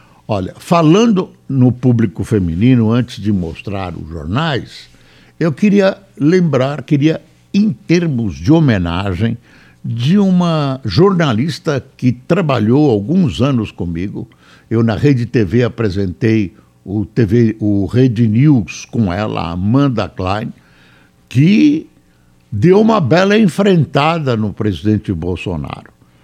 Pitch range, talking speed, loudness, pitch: 100-155 Hz, 110 wpm, -14 LUFS, 120 Hz